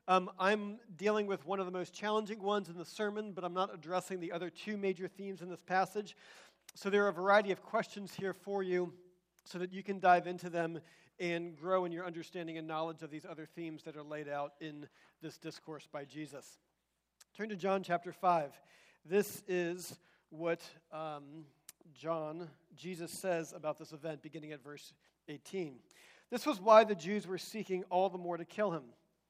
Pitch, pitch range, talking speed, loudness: 180 Hz, 160-195 Hz, 195 wpm, -37 LUFS